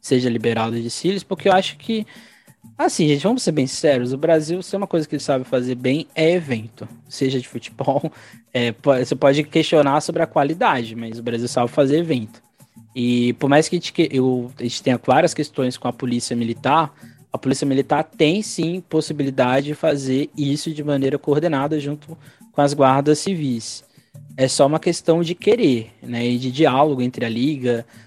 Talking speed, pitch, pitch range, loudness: 190 wpm, 140 Hz, 125-155 Hz, -20 LUFS